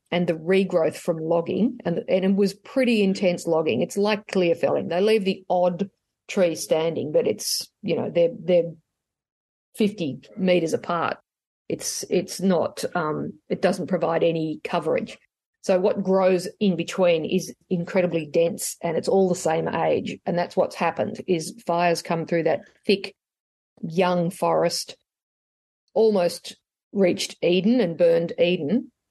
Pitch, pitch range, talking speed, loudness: 180 Hz, 170-200 Hz, 150 wpm, -23 LUFS